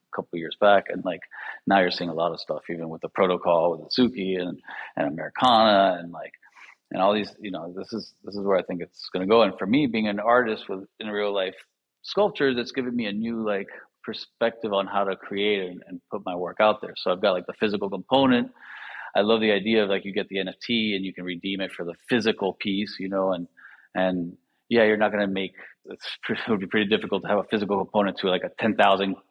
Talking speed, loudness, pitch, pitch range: 250 wpm, -25 LUFS, 100 Hz, 95-110 Hz